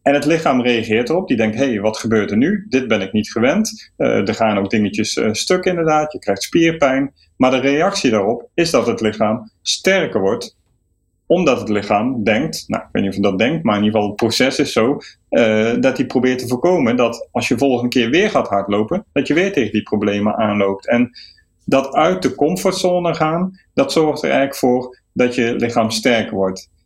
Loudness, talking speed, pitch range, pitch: -17 LUFS, 215 wpm, 105-145 Hz, 120 Hz